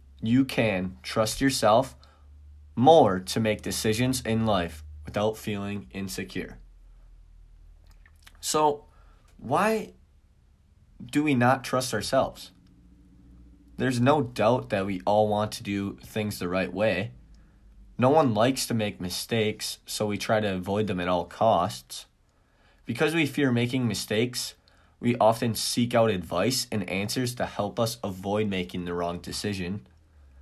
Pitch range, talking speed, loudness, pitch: 85-115 Hz, 135 wpm, -26 LUFS, 100 Hz